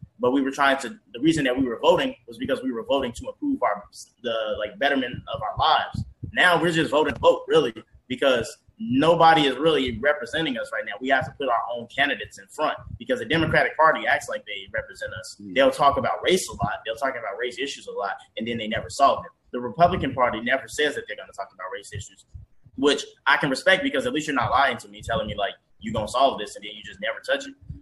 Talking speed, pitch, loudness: 250 wpm, 165 Hz, -23 LUFS